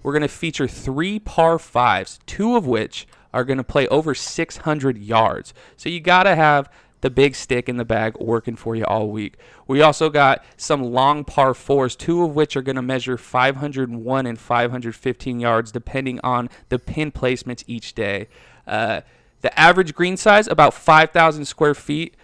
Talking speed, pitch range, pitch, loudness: 170 wpm, 125-155 Hz, 135 Hz, -19 LUFS